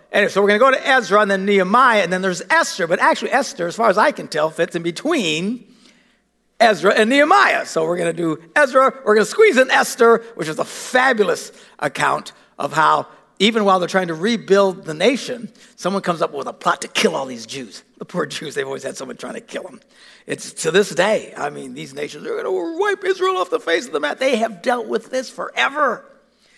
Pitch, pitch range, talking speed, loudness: 230 Hz, 190-270 Hz, 235 wpm, -17 LUFS